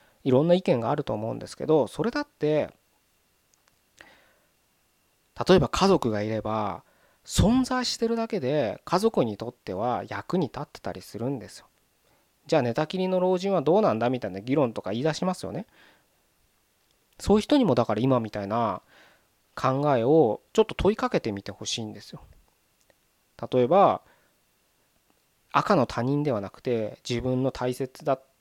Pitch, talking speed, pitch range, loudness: 135 Hz, 310 characters per minute, 115-185 Hz, -26 LUFS